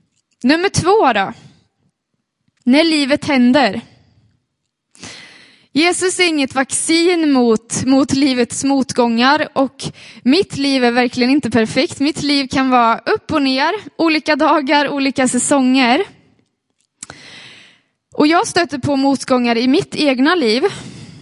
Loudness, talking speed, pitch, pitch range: -14 LUFS, 115 wpm, 275 Hz, 255-310 Hz